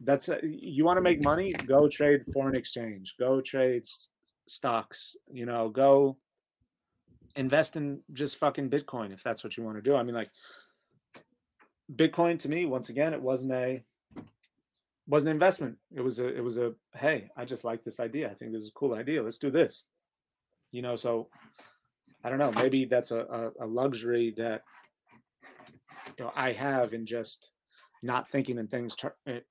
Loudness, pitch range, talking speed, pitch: -30 LUFS, 120-145 Hz, 185 wpm, 130 Hz